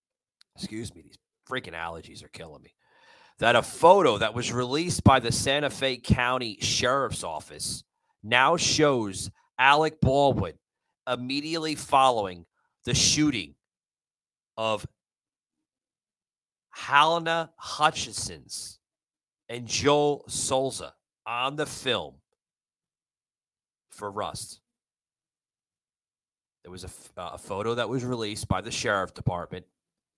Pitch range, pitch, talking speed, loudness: 110-140 Hz, 125 Hz, 105 wpm, -25 LUFS